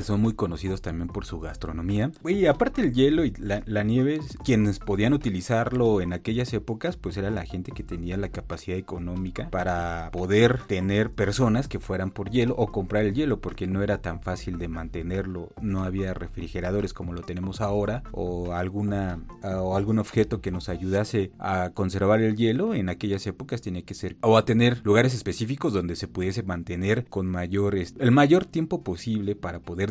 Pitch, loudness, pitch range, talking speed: 100 Hz, -26 LUFS, 90-110 Hz, 185 wpm